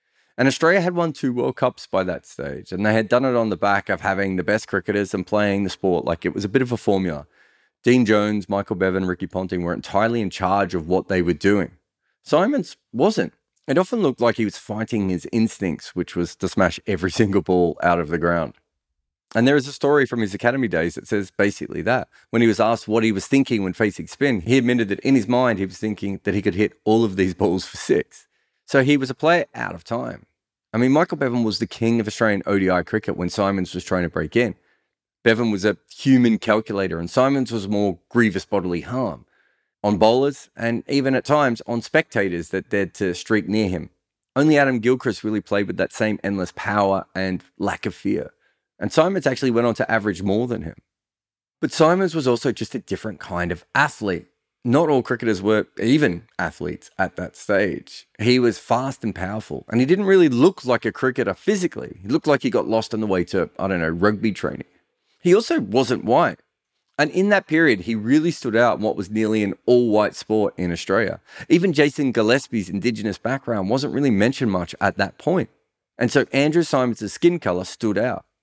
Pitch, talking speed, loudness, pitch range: 110 Hz, 215 wpm, -21 LUFS, 95-125 Hz